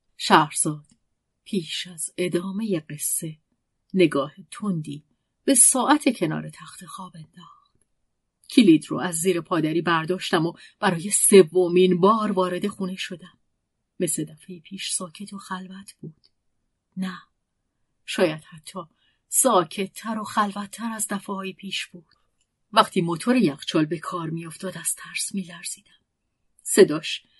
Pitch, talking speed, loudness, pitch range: 185 Hz, 125 wpm, -22 LUFS, 170-200 Hz